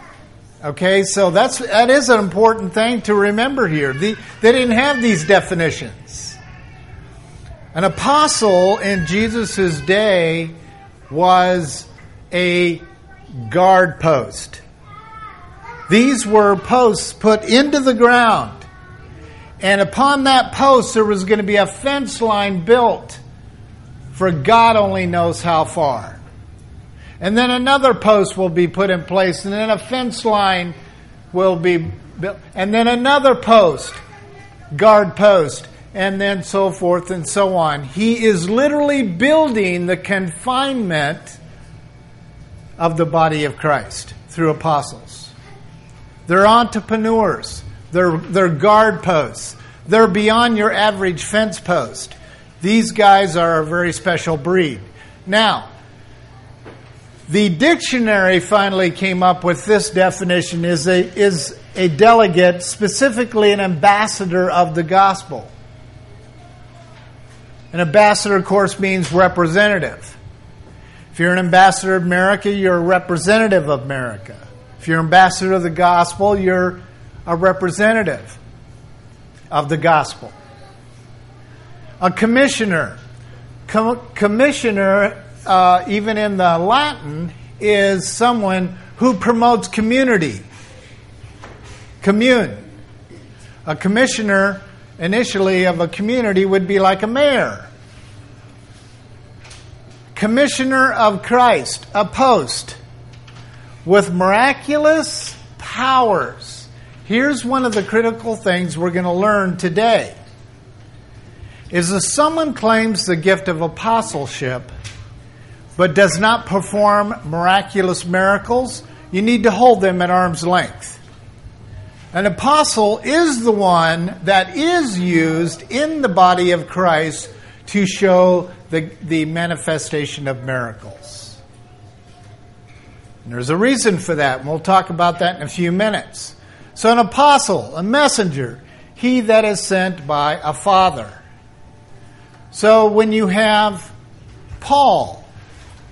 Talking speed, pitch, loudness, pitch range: 115 wpm, 180 Hz, -15 LUFS, 125-210 Hz